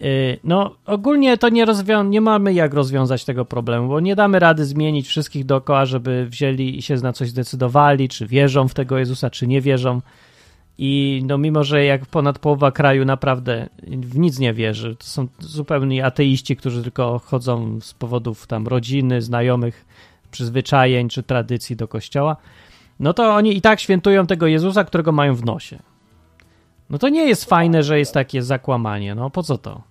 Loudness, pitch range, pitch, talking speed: -18 LUFS, 125-150 Hz, 135 Hz, 175 wpm